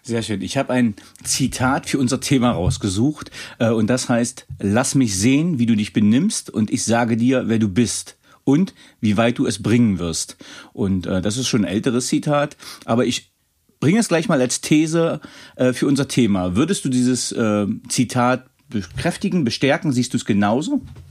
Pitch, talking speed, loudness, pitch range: 125 Hz, 175 wpm, -19 LUFS, 110-140 Hz